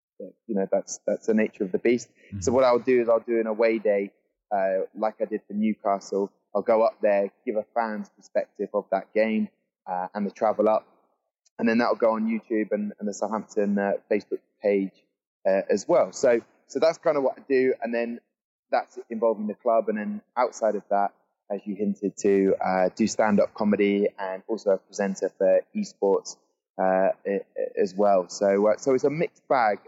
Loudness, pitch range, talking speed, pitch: -25 LUFS, 100-115 Hz, 200 wpm, 105 Hz